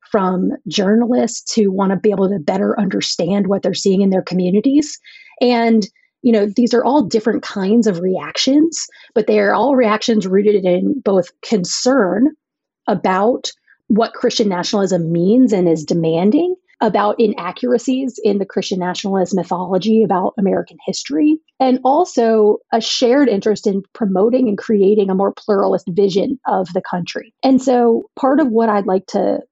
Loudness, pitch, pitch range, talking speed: -16 LUFS, 215 Hz, 195-250 Hz, 155 wpm